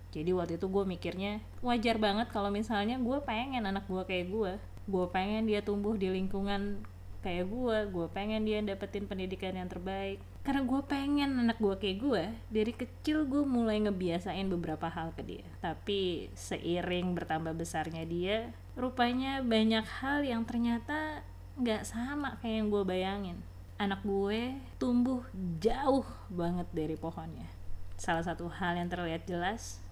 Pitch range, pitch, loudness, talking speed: 175-230 Hz, 195 Hz, -34 LUFS, 150 wpm